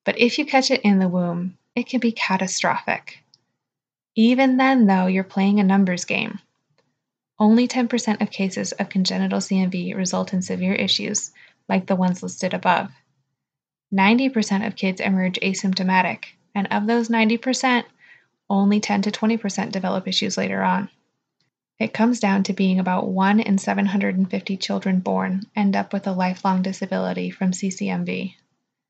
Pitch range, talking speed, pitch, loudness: 185-215 Hz, 150 wpm, 195 Hz, -21 LUFS